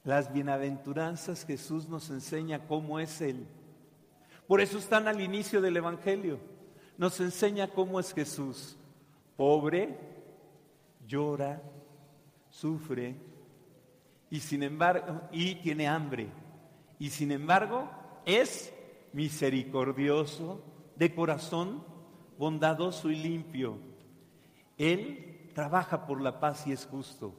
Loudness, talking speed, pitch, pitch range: -32 LUFS, 105 wpm, 155 Hz, 145-175 Hz